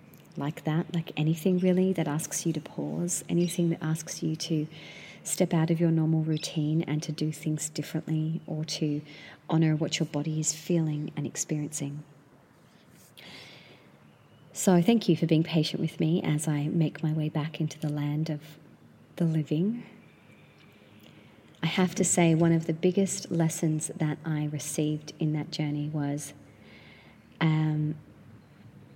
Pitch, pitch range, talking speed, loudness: 155 Hz, 150-170 Hz, 150 wpm, -29 LUFS